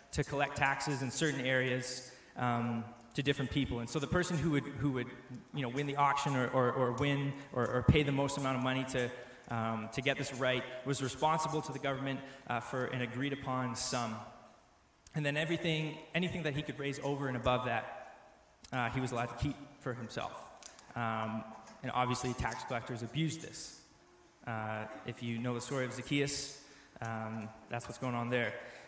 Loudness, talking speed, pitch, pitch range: -36 LUFS, 195 wpm, 130 Hz, 120-140 Hz